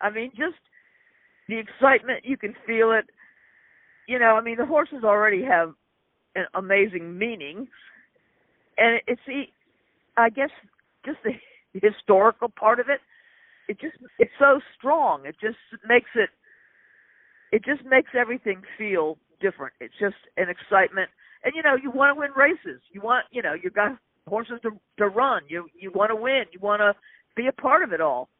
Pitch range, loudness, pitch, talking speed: 210-280 Hz, -23 LUFS, 240 Hz, 175 wpm